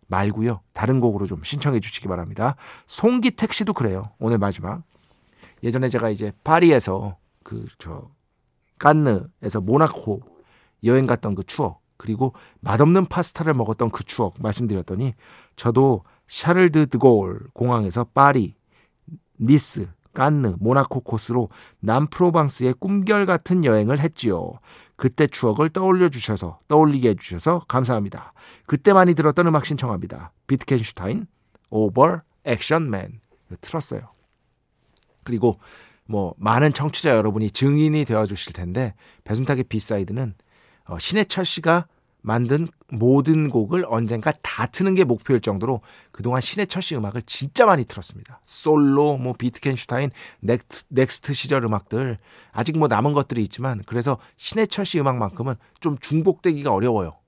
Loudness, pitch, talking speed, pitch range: -21 LUFS, 130 Hz, 315 characters per minute, 110-150 Hz